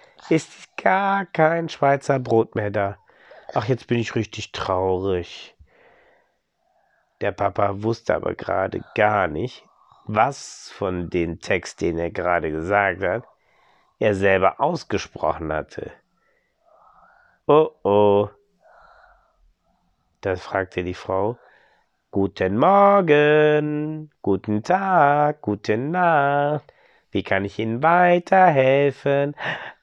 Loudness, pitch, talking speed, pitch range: -21 LUFS, 115 Hz, 100 wpm, 100-150 Hz